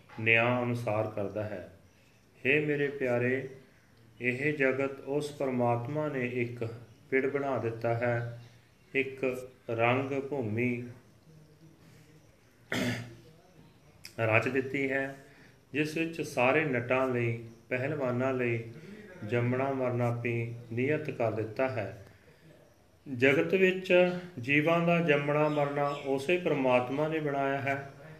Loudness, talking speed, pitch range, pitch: -30 LUFS, 100 wpm, 120-145 Hz, 130 Hz